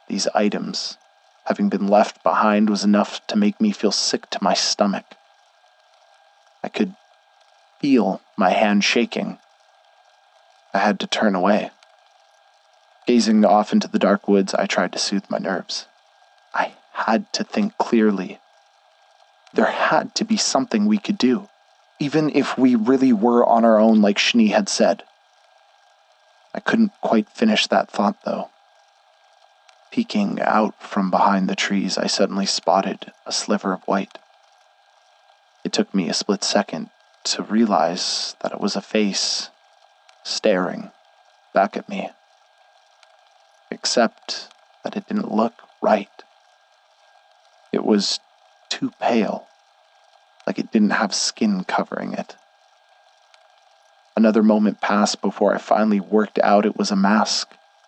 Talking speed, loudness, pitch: 135 wpm, -20 LUFS, 120 Hz